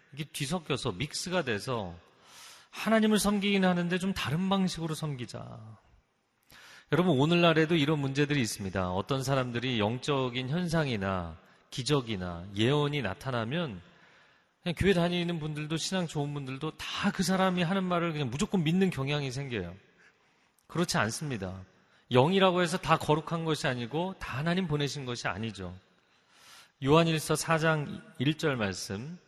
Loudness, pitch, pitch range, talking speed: -30 LUFS, 150 Hz, 120-175 Hz, 315 characters per minute